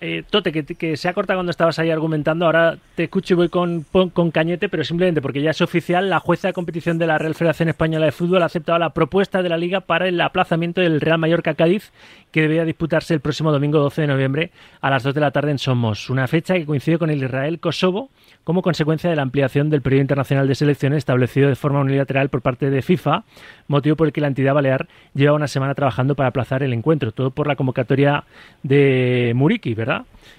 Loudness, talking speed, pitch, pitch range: -19 LUFS, 225 wpm, 155 Hz, 140-170 Hz